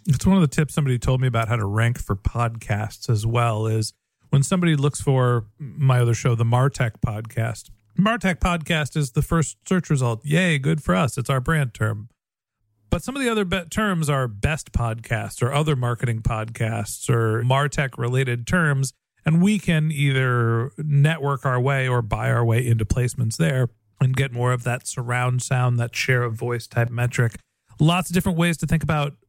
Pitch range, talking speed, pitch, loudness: 115-150 Hz, 195 wpm, 125 Hz, -22 LUFS